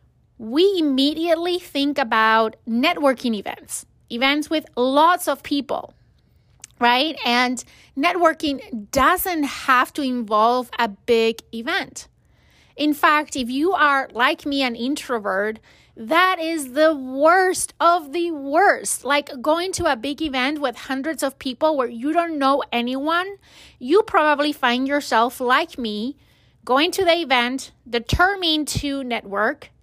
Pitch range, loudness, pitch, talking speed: 250-320 Hz, -20 LUFS, 280 Hz, 130 wpm